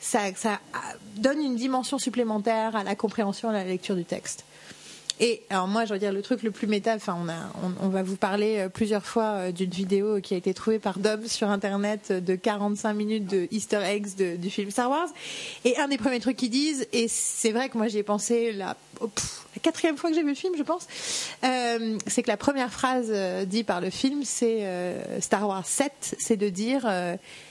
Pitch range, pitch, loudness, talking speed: 200-245 Hz, 215 Hz, -27 LUFS, 225 wpm